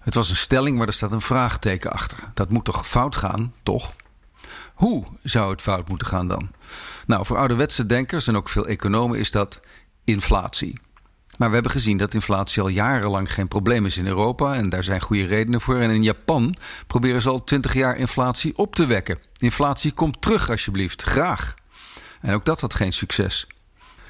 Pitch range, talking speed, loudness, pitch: 100-125 Hz, 190 wpm, -22 LUFS, 110 Hz